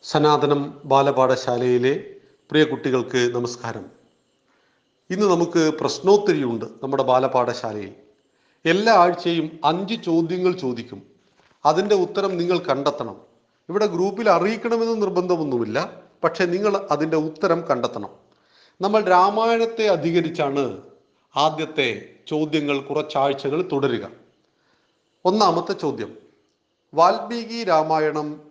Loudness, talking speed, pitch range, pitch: -21 LUFS, 80 wpm, 135-185 Hz, 155 Hz